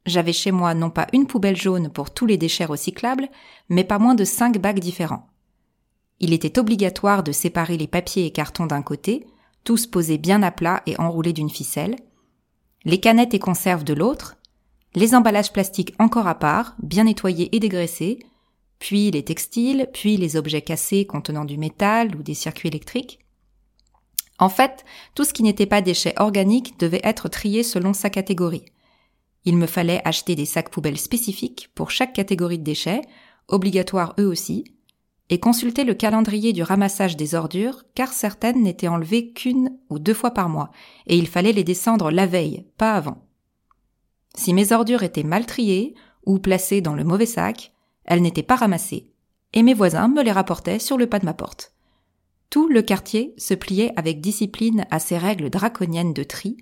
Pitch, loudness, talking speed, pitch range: 195 Hz, -20 LUFS, 180 wpm, 170-225 Hz